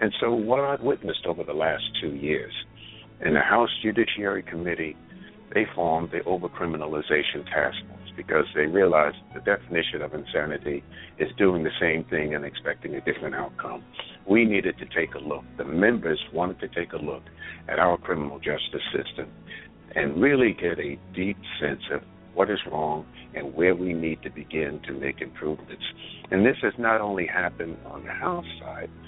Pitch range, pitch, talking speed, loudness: 75-100 Hz, 85 Hz, 175 wpm, -26 LUFS